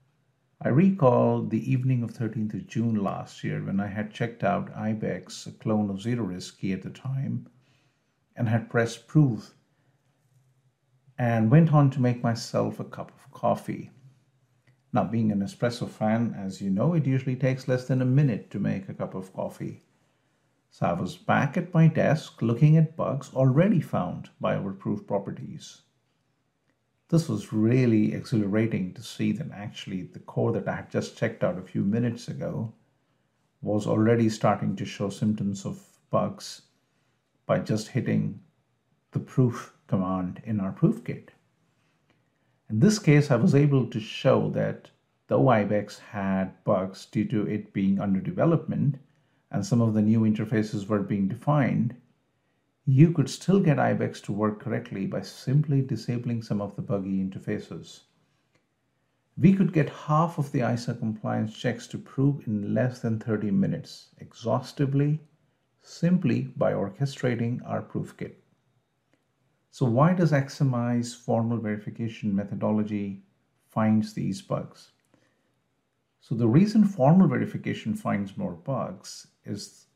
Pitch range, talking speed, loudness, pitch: 110-140 Hz, 150 wpm, -26 LUFS, 125 Hz